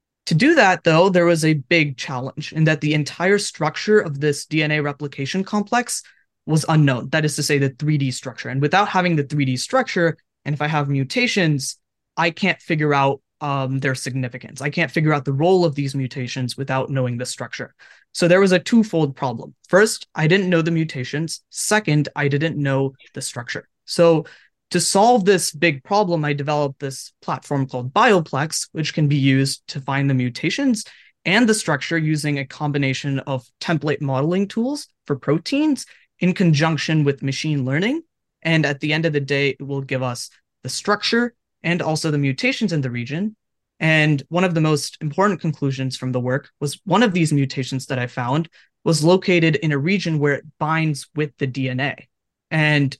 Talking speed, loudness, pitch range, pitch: 185 wpm, -20 LUFS, 135-170 Hz, 150 Hz